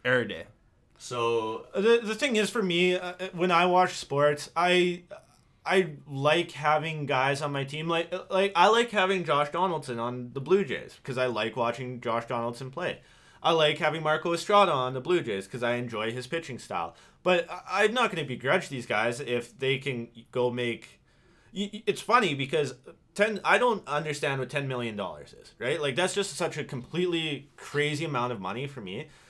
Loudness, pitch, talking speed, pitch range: -28 LUFS, 150 Hz, 190 wpm, 125-180 Hz